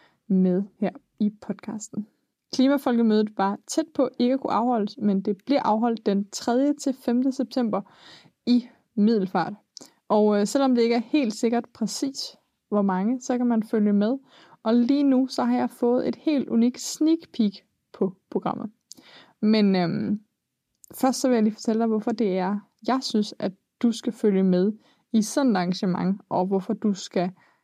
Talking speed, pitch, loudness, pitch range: 175 wpm, 225 Hz, -24 LUFS, 205-250 Hz